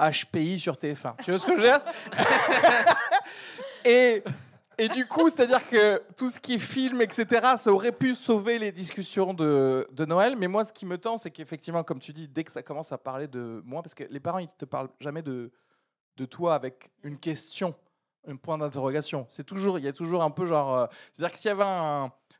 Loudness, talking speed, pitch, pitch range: -26 LUFS, 225 wpm, 175 Hz, 150-230 Hz